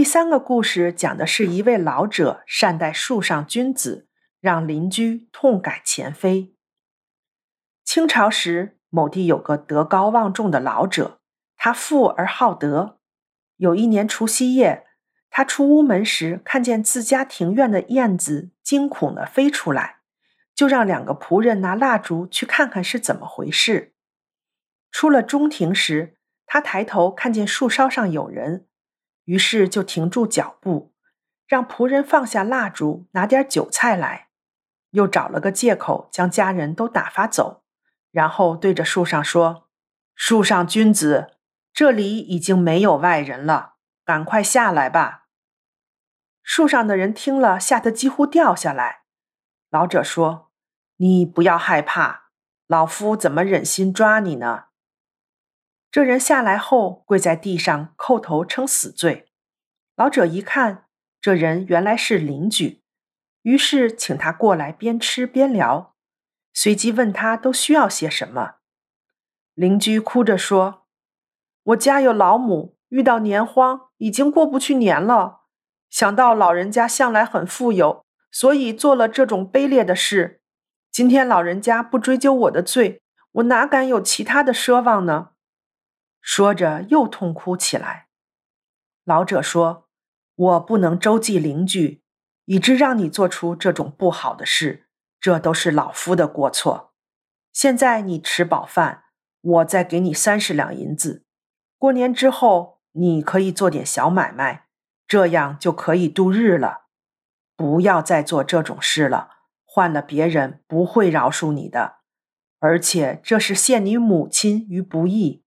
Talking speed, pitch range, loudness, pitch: 205 characters per minute, 175-250 Hz, -18 LUFS, 205 Hz